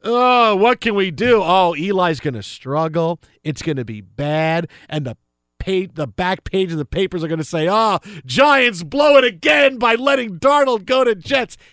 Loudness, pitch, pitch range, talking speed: -17 LUFS, 185 Hz, 155-240 Hz, 200 wpm